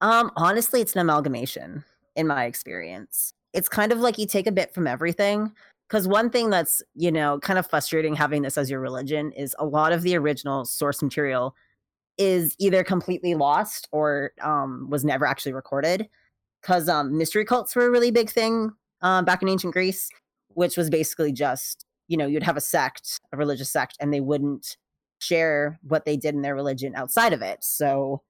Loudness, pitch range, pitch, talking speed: -24 LUFS, 145-190 Hz, 160 Hz, 195 wpm